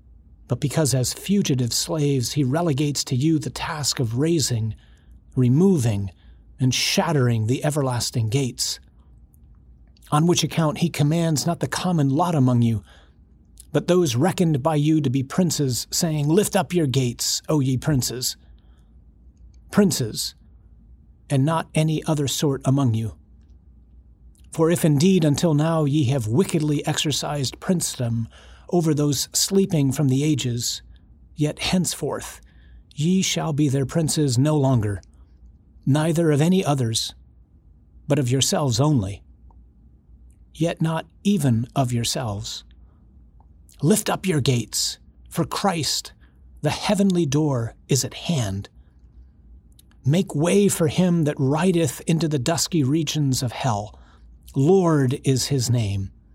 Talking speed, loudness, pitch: 130 wpm, -22 LUFS, 135 Hz